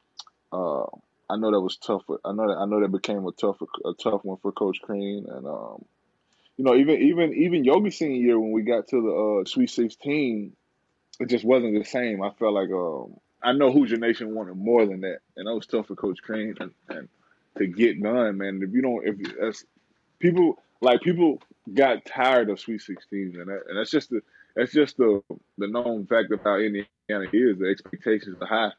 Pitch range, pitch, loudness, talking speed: 100-120 Hz, 110 Hz, -24 LUFS, 210 wpm